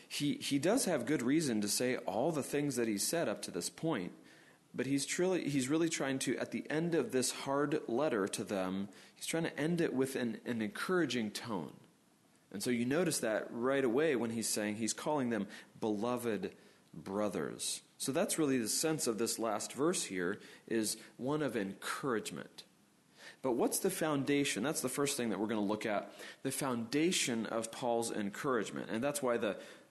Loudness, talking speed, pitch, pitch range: -35 LUFS, 195 wpm, 125 Hz, 110-145 Hz